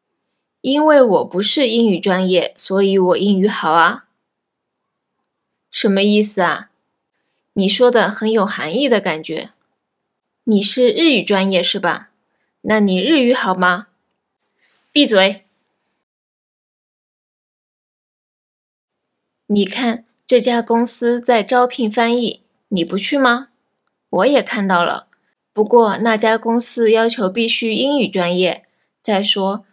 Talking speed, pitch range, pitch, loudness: 170 characters per minute, 195-240 Hz, 220 Hz, -15 LUFS